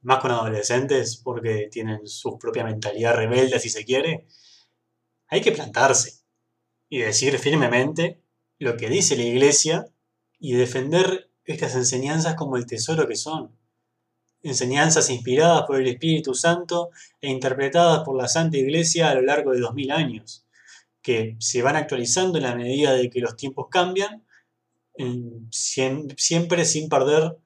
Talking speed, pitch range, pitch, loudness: 140 wpm, 120-160 Hz, 130 Hz, -22 LUFS